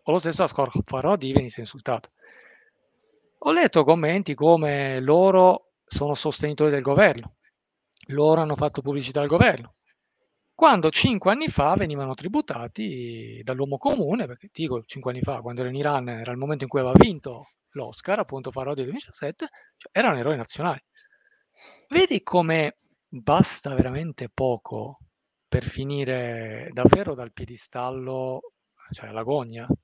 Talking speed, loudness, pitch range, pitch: 135 wpm, -23 LUFS, 125-175 Hz, 140 Hz